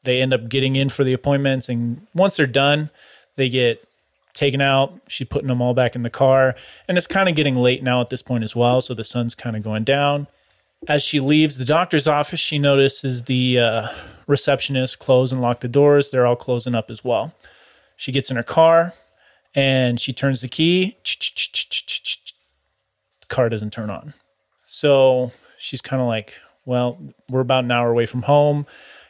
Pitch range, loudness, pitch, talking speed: 120-145 Hz, -19 LUFS, 130 Hz, 190 wpm